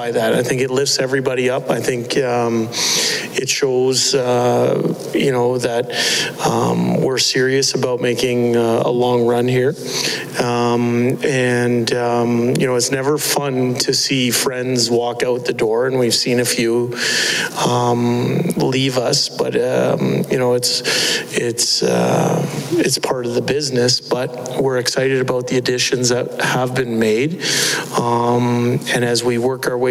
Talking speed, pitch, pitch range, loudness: 155 wpm, 125 Hz, 120-130 Hz, -16 LUFS